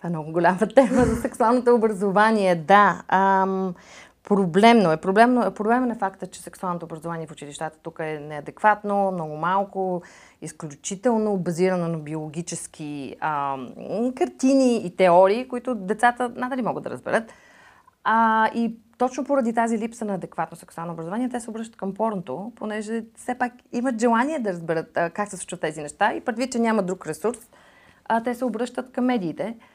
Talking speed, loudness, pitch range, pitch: 160 wpm, -23 LUFS, 175-235 Hz, 205 Hz